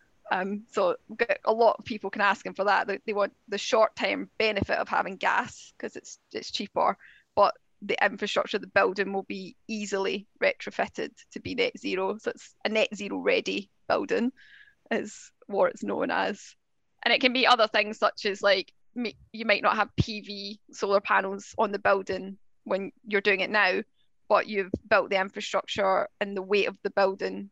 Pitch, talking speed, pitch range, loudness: 205 Hz, 185 wpm, 195-225 Hz, -27 LUFS